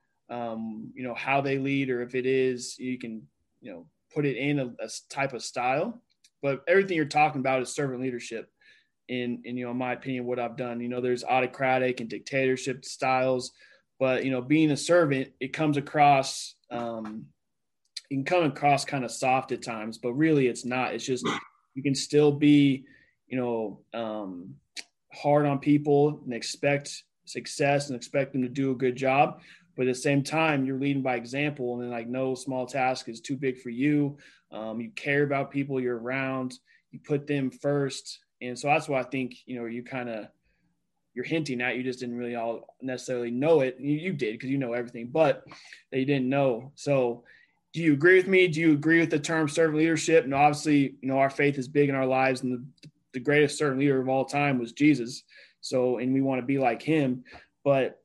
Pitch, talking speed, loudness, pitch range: 130 Hz, 210 wpm, -27 LUFS, 125-145 Hz